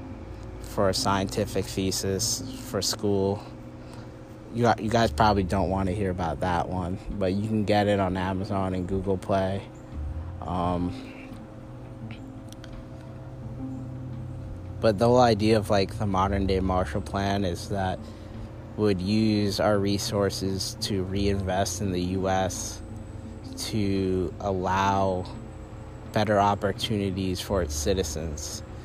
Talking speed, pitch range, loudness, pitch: 125 wpm, 95-110 Hz, -26 LUFS, 100 Hz